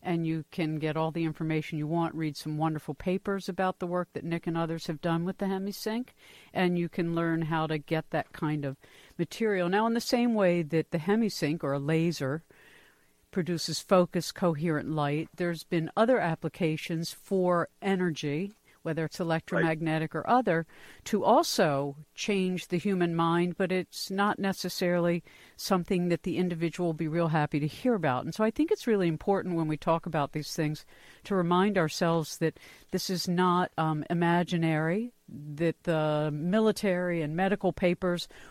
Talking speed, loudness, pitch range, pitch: 175 wpm, -29 LUFS, 160-185 Hz, 170 Hz